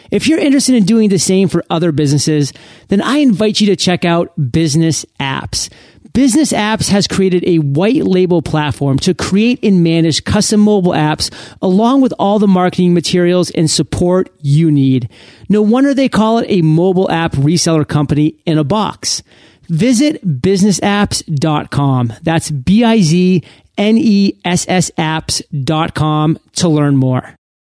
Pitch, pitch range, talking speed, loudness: 175 Hz, 155-205 Hz, 155 wpm, -12 LUFS